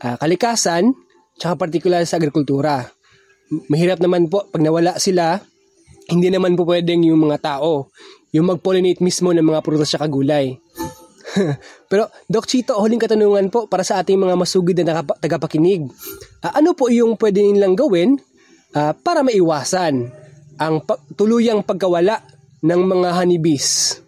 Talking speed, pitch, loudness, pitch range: 145 wpm, 180 Hz, -17 LUFS, 160-205 Hz